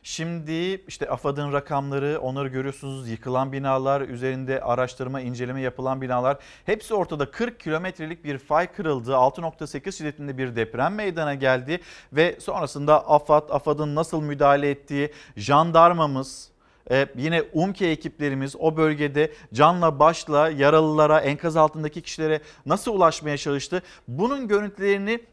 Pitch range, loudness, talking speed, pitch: 135-160 Hz, -23 LUFS, 120 wpm, 150 Hz